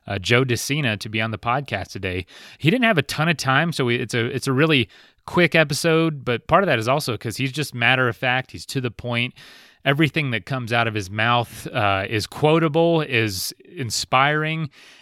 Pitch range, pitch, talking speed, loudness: 115-150 Hz, 130 Hz, 210 wpm, -21 LUFS